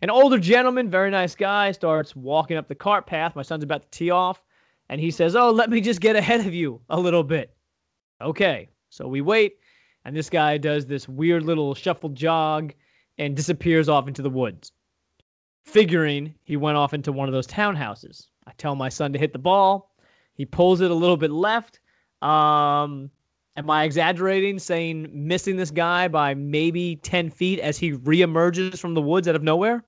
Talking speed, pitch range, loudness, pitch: 195 wpm, 150-185 Hz, -22 LUFS, 165 Hz